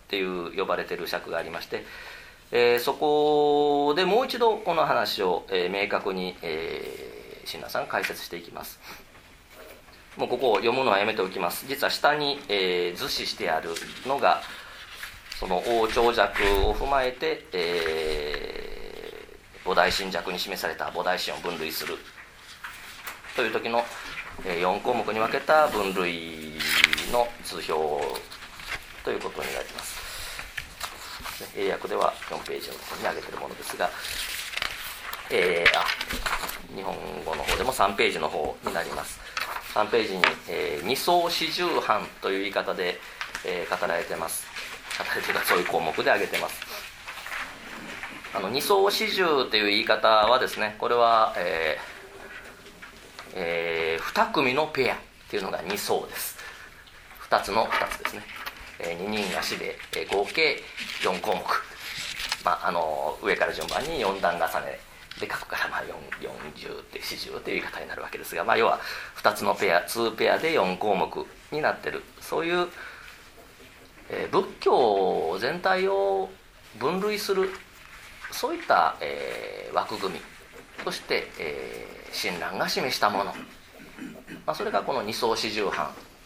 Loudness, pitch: -26 LUFS, 245 Hz